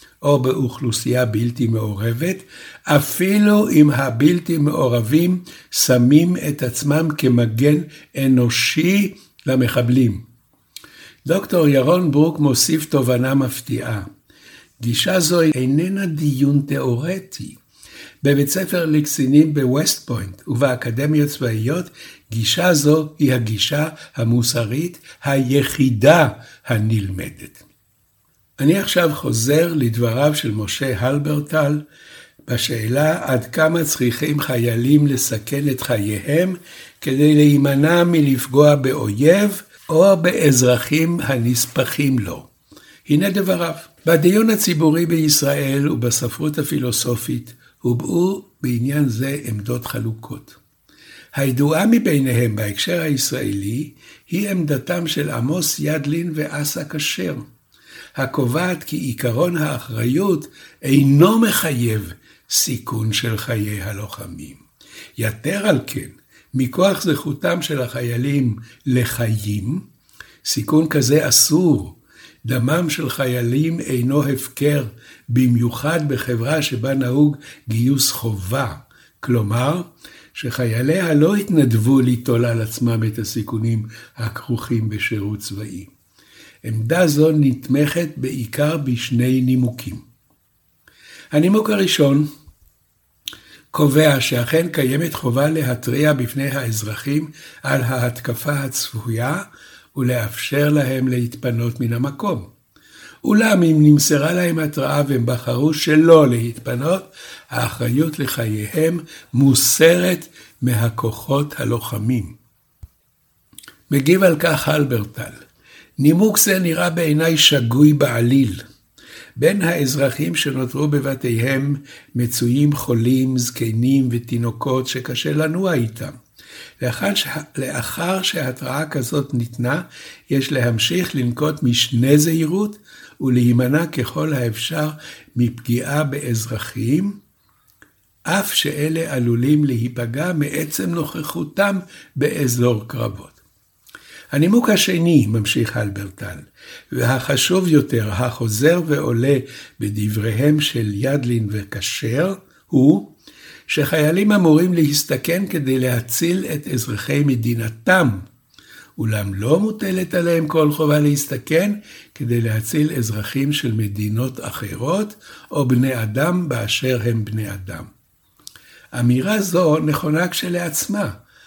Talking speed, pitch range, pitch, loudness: 90 wpm, 120-155 Hz, 140 Hz, -18 LUFS